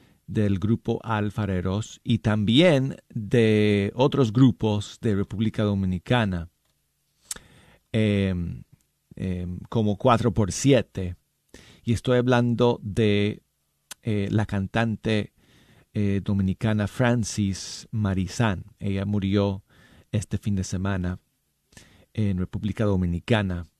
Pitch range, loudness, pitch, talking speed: 95-115 Hz, -25 LUFS, 105 Hz, 95 wpm